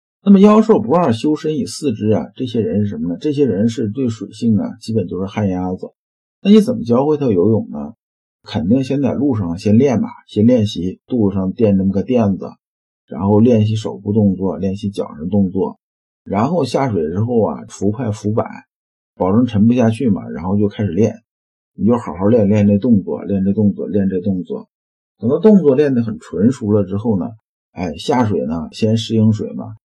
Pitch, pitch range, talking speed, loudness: 110 Hz, 100-125 Hz, 285 characters per minute, -16 LUFS